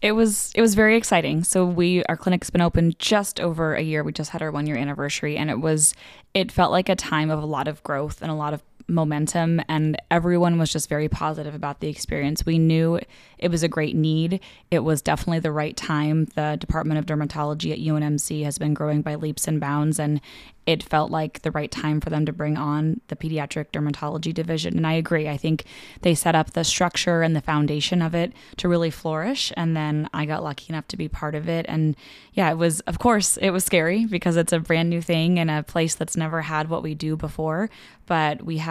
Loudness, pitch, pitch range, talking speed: -23 LUFS, 155 Hz, 150-170 Hz, 235 wpm